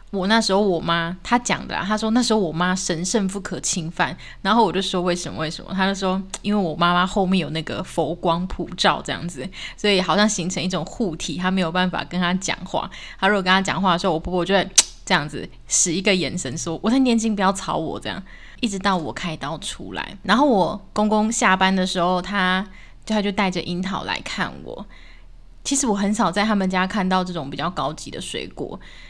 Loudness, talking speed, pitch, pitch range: -21 LUFS, 325 characters per minute, 185 Hz, 175-205 Hz